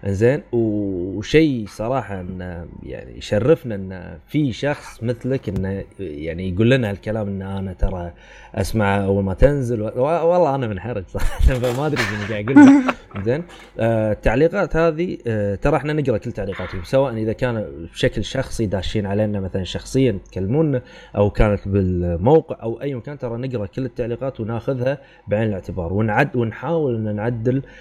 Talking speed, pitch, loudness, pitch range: 145 wpm, 110 Hz, -20 LUFS, 100-130 Hz